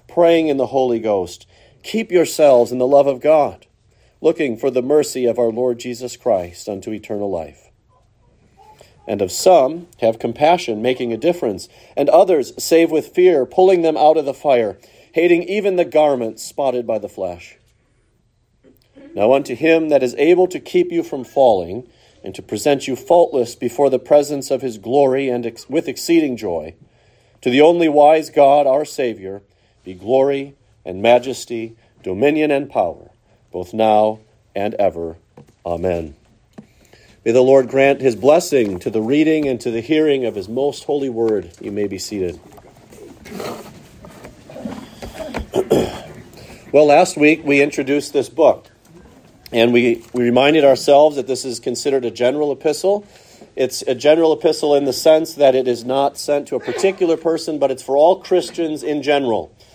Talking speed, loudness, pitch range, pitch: 160 wpm, -16 LUFS, 120-155 Hz, 135 Hz